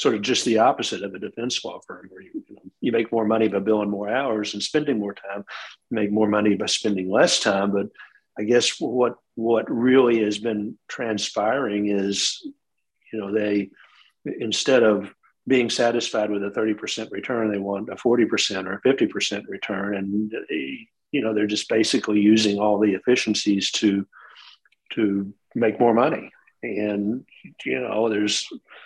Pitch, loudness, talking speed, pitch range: 105 Hz, -22 LUFS, 170 wpm, 105-120 Hz